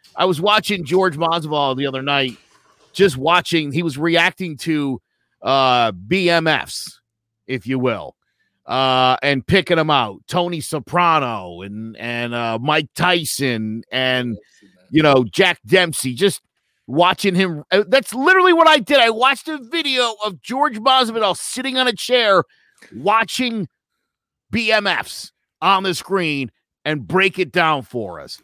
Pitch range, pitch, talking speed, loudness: 130-200 Hz, 170 Hz, 140 wpm, -17 LUFS